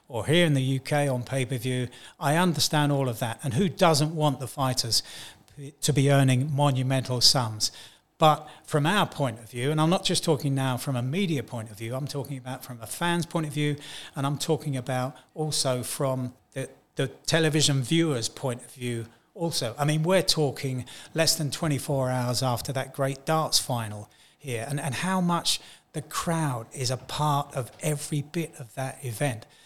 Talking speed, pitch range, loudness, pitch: 190 wpm, 130-155 Hz, -26 LUFS, 140 Hz